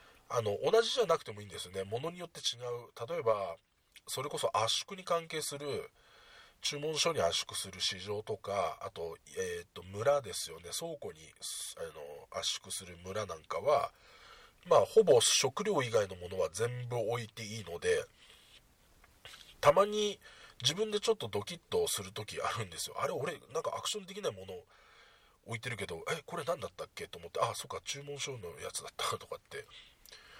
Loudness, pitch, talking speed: -35 LUFS, 165 Hz, 345 characters per minute